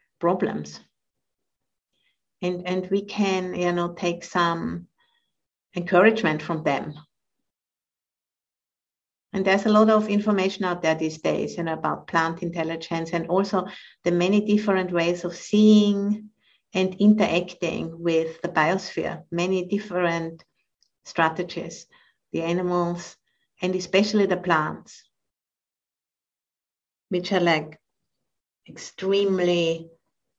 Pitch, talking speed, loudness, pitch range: 175 Hz, 105 wpm, -24 LUFS, 165-195 Hz